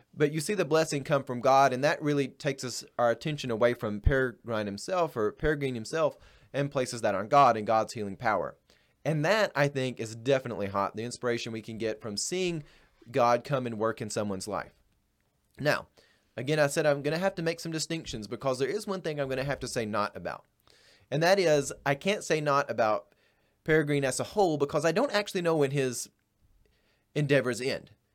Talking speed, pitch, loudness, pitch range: 210 wpm, 135 Hz, -29 LUFS, 115-155 Hz